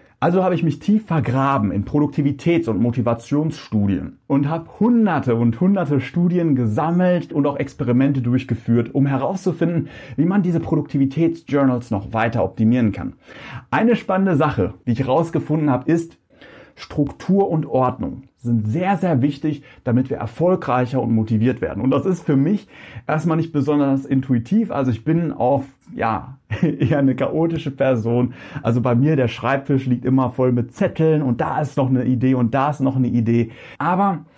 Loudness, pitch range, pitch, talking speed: -19 LUFS, 125-160 Hz, 140 Hz, 160 wpm